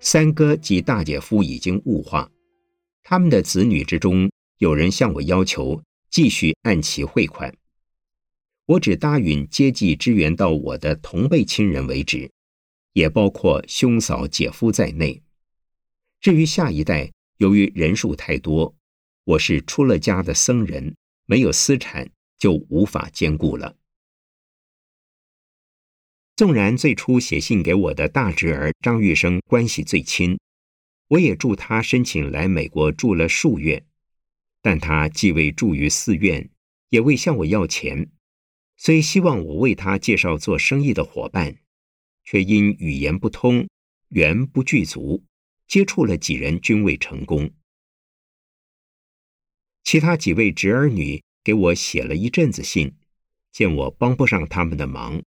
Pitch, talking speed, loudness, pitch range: 95 Hz, 205 characters per minute, -19 LUFS, 75-125 Hz